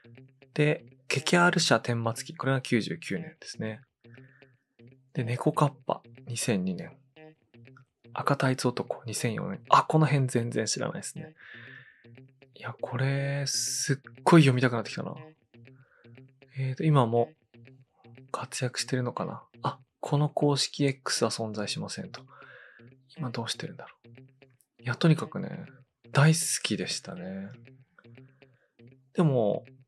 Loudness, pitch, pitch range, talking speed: -28 LUFS, 130 Hz, 120-140 Hz, 225 characters per minute